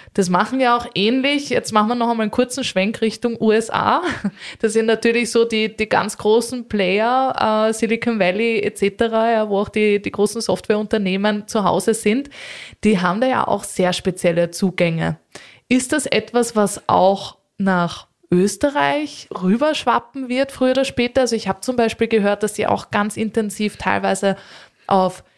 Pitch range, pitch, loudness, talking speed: 195-235 Hz, 215 Hz, -19 LUFS, 170 wpm